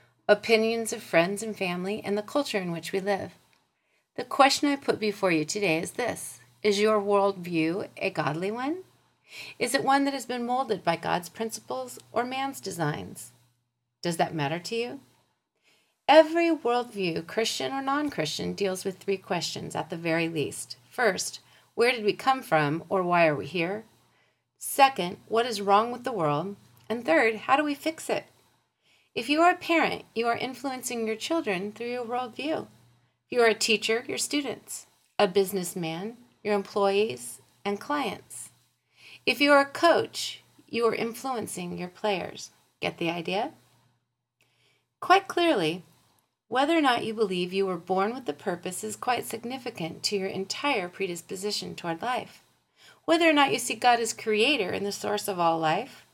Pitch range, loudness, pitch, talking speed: 180-245 Hz, -27 LUFS, 210 Hz, 170 wpm